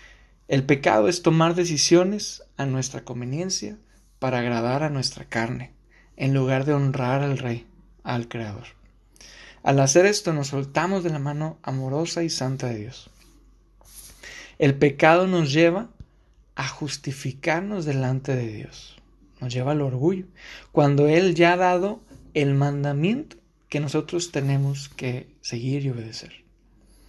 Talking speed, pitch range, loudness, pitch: 135 wpm, 130-165 Hz, -23 LUFS, 140 Hz